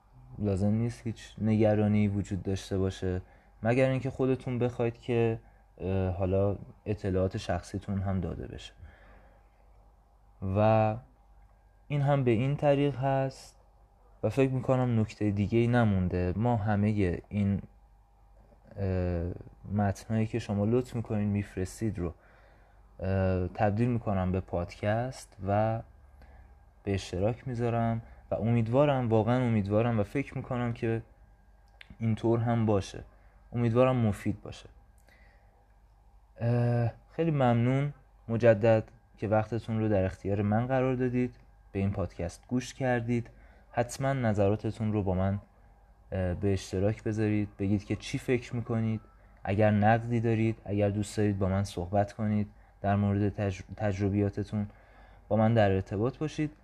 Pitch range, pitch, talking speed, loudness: 100-115 Hz, 105 Hz, 120 wpm, -30 LUFS